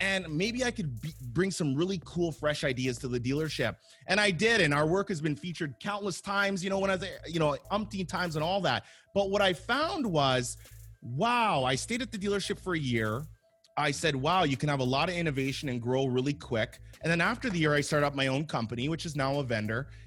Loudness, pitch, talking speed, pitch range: -30 LUFS, 155 Hz, 240 wpm, 135-195 Hz